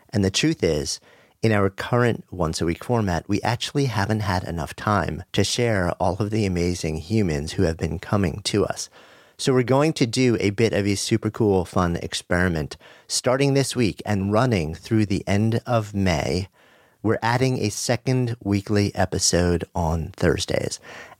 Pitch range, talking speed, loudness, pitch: 90-115 Hz, 175 wpm, -23 LUFS, 100 Hz